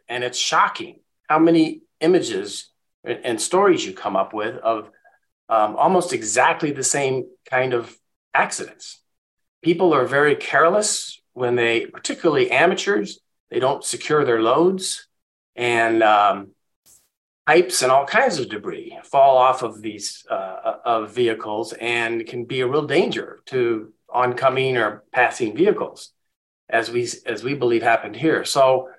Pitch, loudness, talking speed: 150 Hz, -20 LUFS, 140 wpm